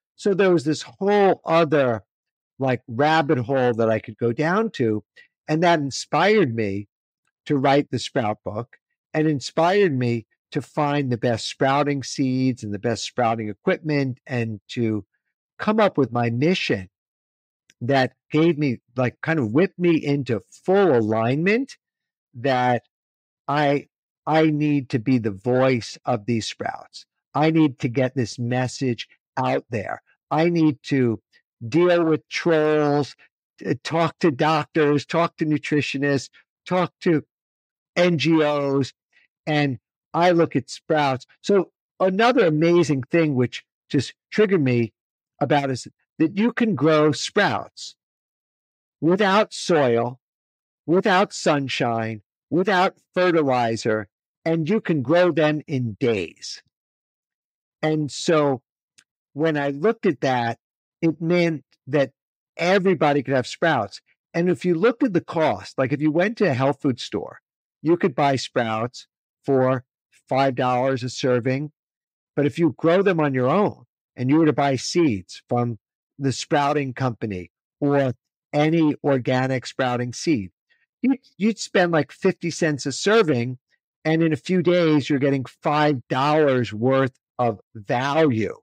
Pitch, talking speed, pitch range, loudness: 145 Hz, 135 wpm, 125-165 Hz, -22 LUFS